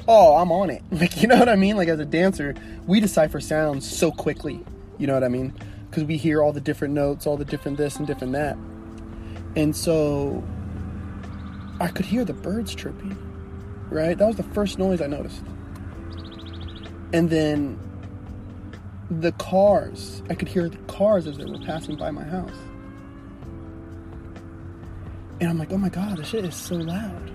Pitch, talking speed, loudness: 140 Hz, 180 wpm, -23 LUFS